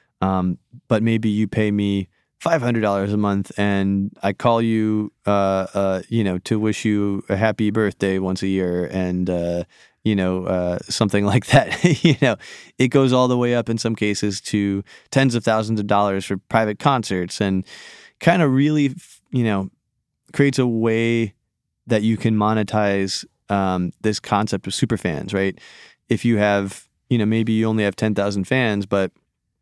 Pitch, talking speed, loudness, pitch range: 105 Hz, 180 wpm, -20 LUFS, 95-115 Hz